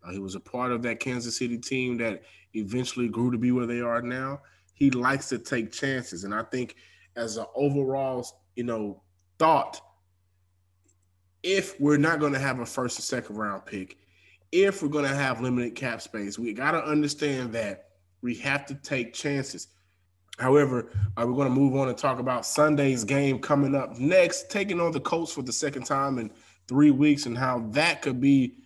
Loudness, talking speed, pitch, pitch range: -27 LUFS, 195 wpm, 125 Hz, 110-140 Hz